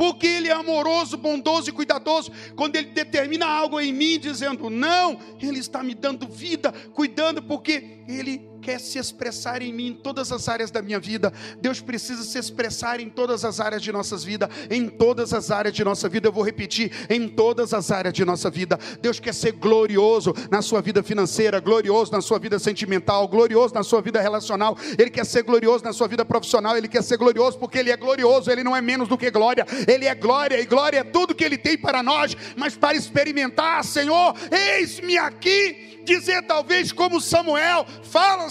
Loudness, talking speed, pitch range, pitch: -21 LUFS, 200 wpm, 220-295 Hz, 245 Hz